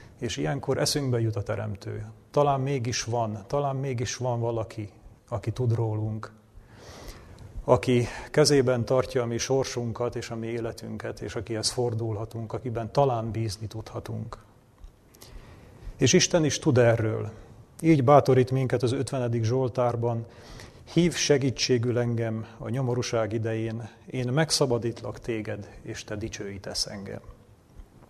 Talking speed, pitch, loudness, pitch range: 120 wpm, 115 Hz, -27 LUFS, 110-125 Hz